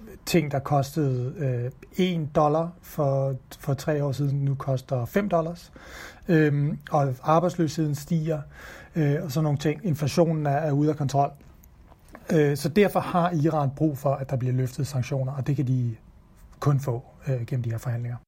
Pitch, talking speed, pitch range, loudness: 145 Hz, 175 wpm, 135-160 Hz, -26 LUFS